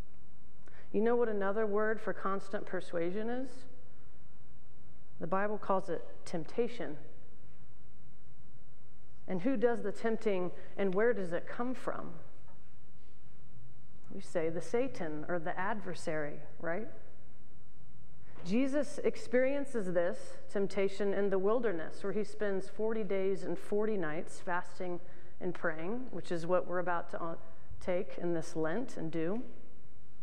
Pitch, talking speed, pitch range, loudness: 195 Hz, 125 wpm, 175-220 Hz, -36 LUFS